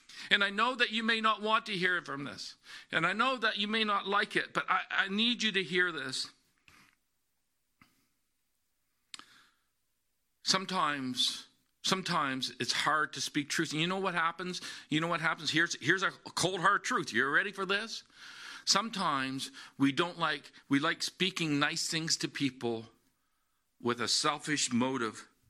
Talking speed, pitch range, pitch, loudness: 165 wpm, 140-200 Hz, 170 Hz, -31 LUFS